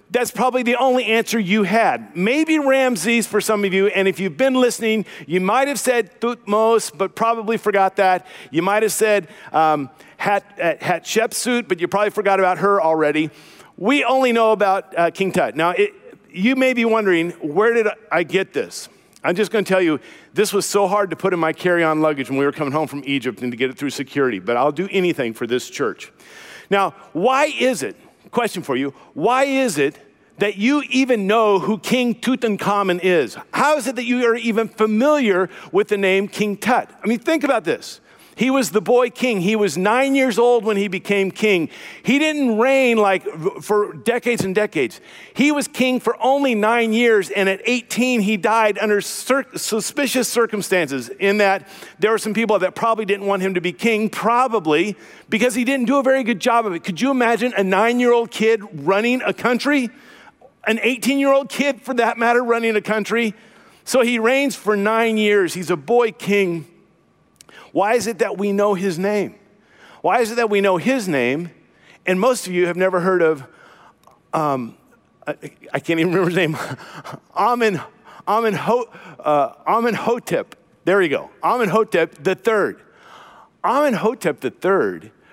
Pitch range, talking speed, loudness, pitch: 190-240 Hz, 185 wpm, -18 LUFS, 215 Hz